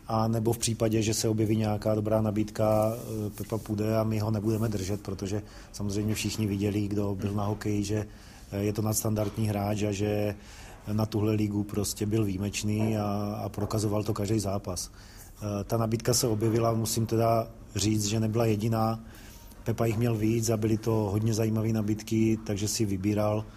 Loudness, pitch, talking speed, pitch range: -29 LUFS, 110 Hz, 170 wpm, 105-110 Hz